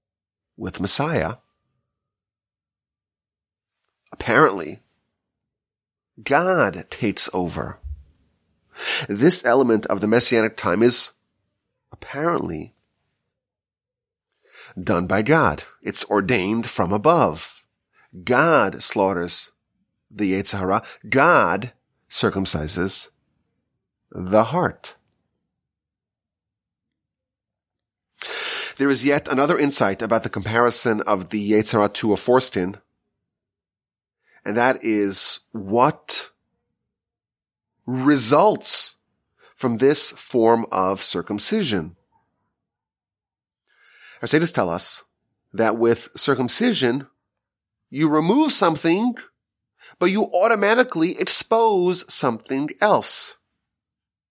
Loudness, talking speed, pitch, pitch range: -19 LUFS, 75 wpm, 115 Hz, 95-140 Hz